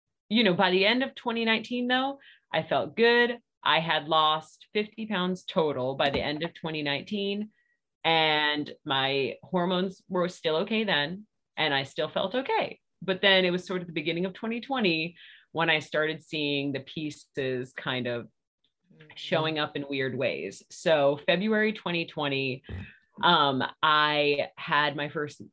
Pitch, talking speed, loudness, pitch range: 165 Hz, 155 wpm, -27 LUFS, 150-200 Hz